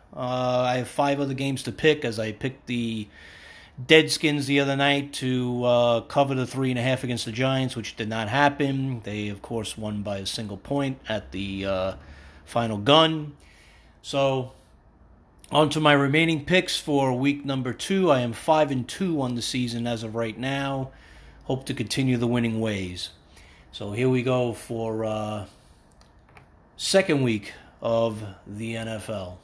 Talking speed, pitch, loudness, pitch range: 170 wpm, 125 Hz, -25 LUFS, 110-140 Hz